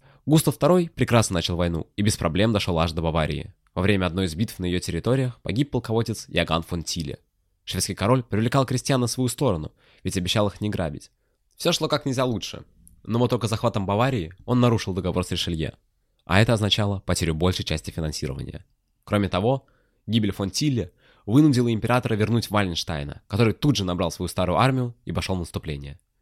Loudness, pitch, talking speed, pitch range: -24 LUFS, 105 Hz, 185 wpm, 90-125 Hz